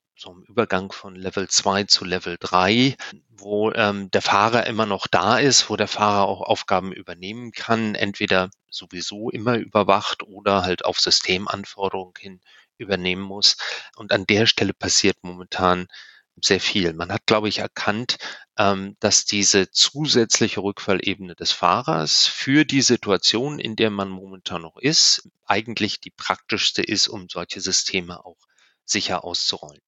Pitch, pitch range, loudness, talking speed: 100 Hz, 95-105 Hz, -20 LUFS, 150 wpm